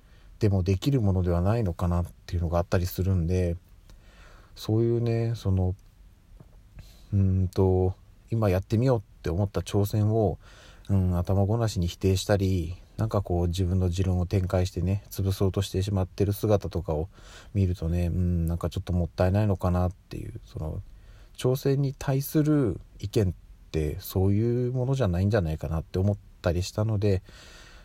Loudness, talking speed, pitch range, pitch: -27 LUFS, 355 characters per minute, 90-105 Hz, 95 Hz